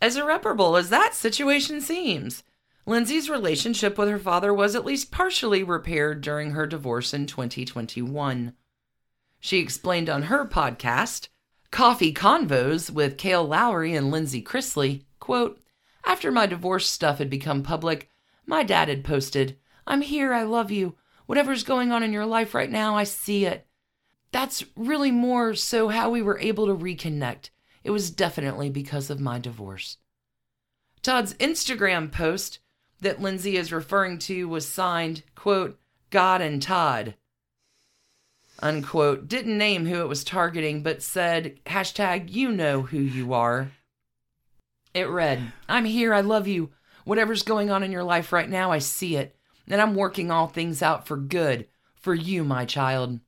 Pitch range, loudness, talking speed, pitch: 145-215 Hz, -24 LUFS, 155 wpm, 175 Hz